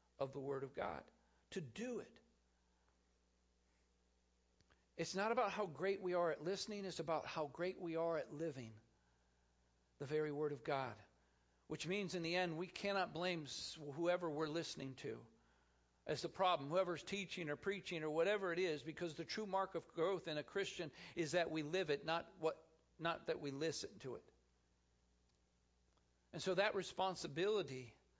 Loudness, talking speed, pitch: -43 LUFS, 170 wpm, 155 Hz